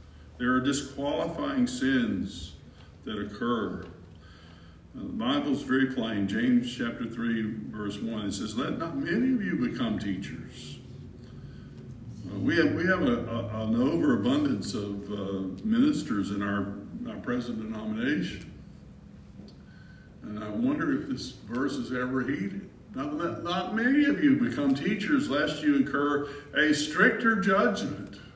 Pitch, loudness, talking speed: 140 Hz, -28 LUFS, 135 wpm